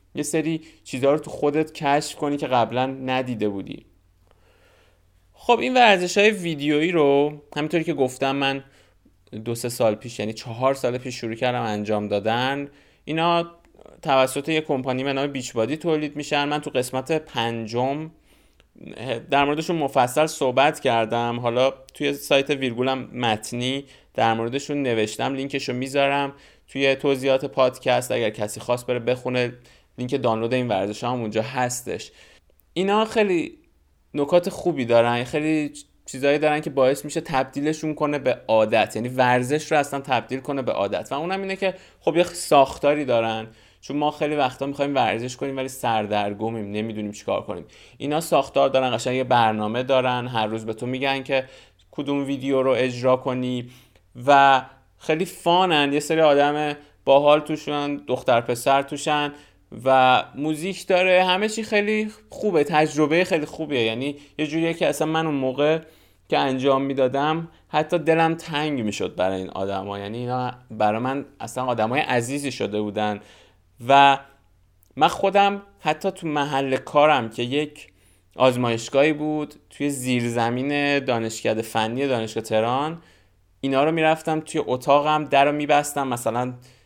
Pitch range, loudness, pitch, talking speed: 120-150 Hz, -22 LUFS, 135 Hz, 145 wpm